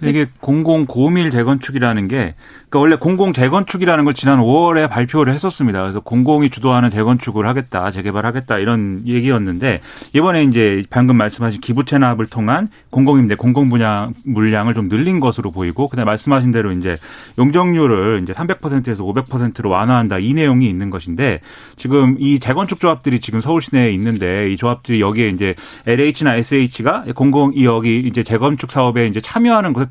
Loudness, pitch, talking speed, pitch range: -15 LUFS, 125 Hz, 400 characters per minute, 110-140 Hz